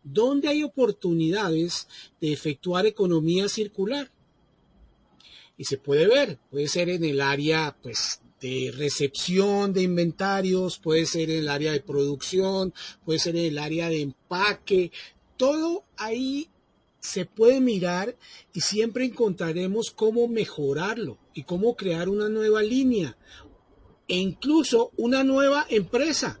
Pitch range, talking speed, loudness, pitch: 160-230 Hz, 125 wpm, -25 LUFS, 190 Hz